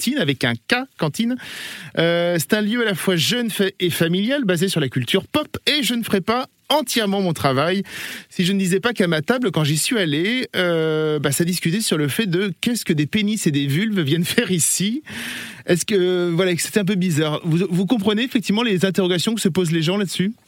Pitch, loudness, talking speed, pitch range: 190 Hz, -20 LUFS, 225 wpm, 170-220 Hz